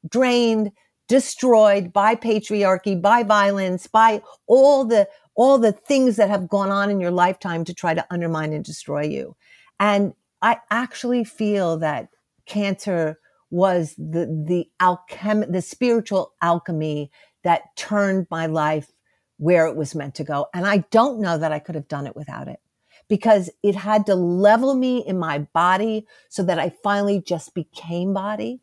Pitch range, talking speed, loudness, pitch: 170-215 Hz, 160 wpm, -20 LUFS, 195 Hz